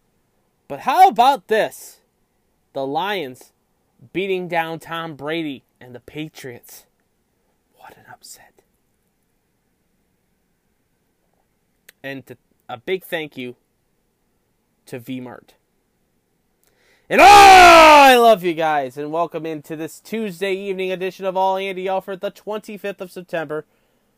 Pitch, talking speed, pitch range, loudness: 180 Hz, 115 wpm, 155-200 Hz, -14 LUFS